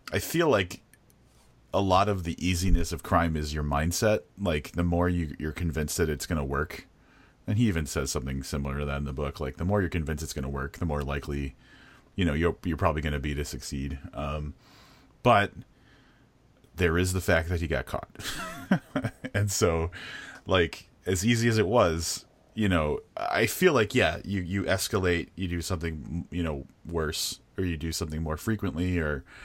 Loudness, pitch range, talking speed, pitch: -28 LUFS, 75-100 Hz, 200 wpm, 85 Hz